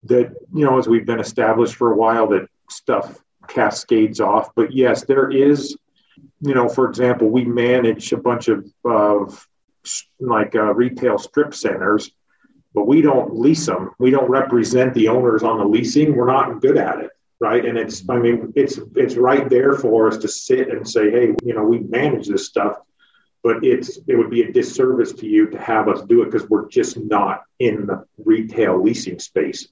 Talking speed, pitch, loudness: 195 wpm, 130 Hz, -17 LUFS